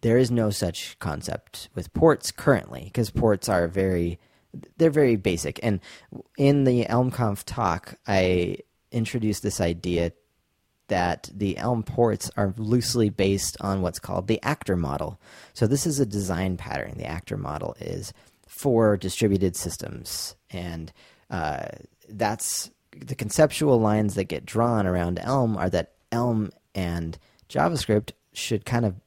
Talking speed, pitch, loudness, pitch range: 140 wpm, 105 Hz, -25 LUFS, 90-120 Hz